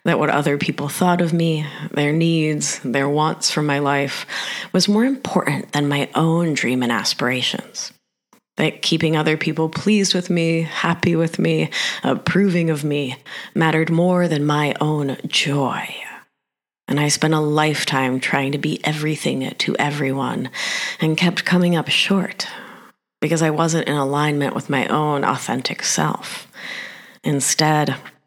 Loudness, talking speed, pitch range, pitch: -19 LUFS, 145 wpm, 145-170 Hz, 155 Hz